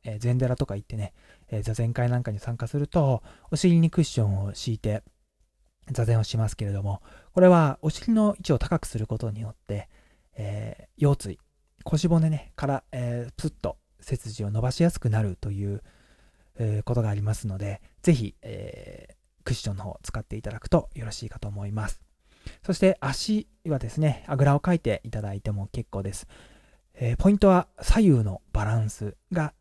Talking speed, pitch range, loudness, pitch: 340 characters per minute, 105-145 Hz, -26 LUFS, 115 Hz